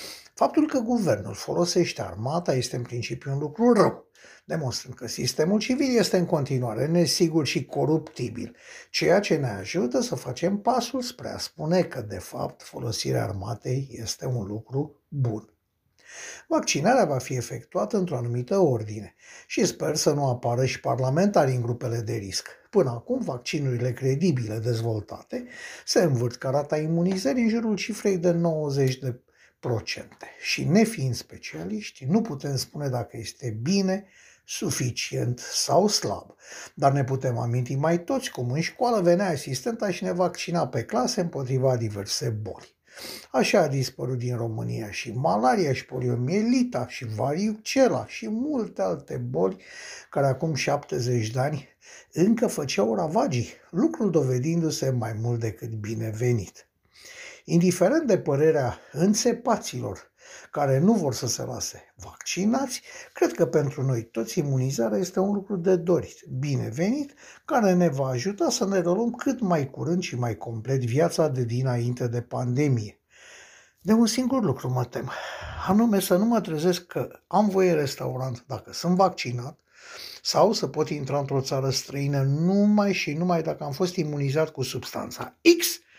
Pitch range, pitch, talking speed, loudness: 125-190 Hz, 145 Hz, 145 wpm, -25 LUFS